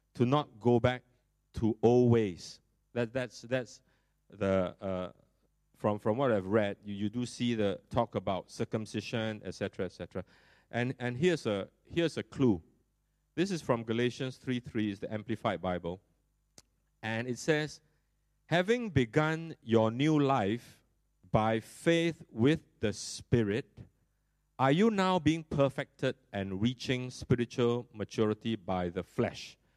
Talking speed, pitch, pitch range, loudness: 140 wpm, 120 Hz, 105-130 Hz, -32 LUFS